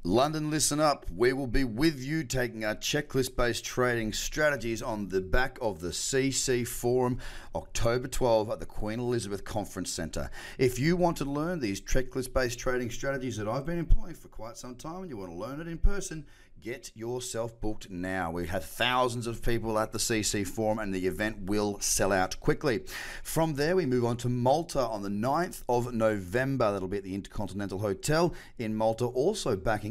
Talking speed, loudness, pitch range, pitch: 195 wpm, -30 LUFS, 105-135 Hz, 120 Hz